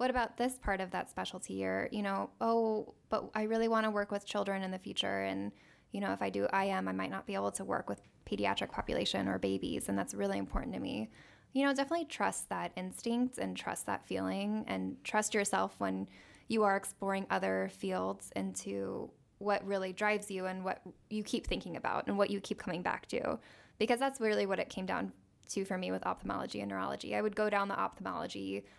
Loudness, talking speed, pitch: -36 LUFS, 220 wpm, 185 Hz